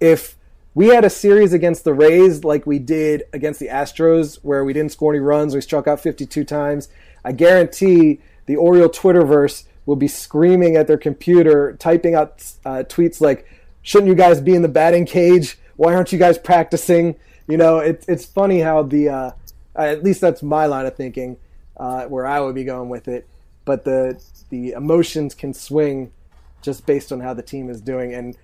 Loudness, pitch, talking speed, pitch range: -15 LUFS, 150 Hz, 195 wpm, 135-170 Hz